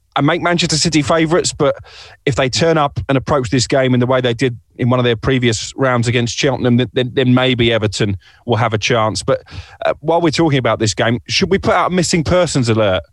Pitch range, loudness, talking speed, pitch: 120-150 Hz, -15 LUFS, 240 wpm, 130 Hz